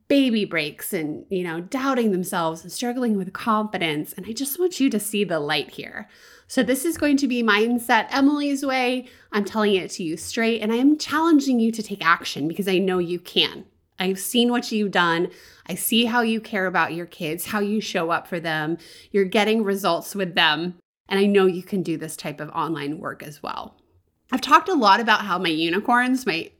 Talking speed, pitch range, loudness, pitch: 215 wpm, 175-240 Hz, -22 LUFS, 200 Hz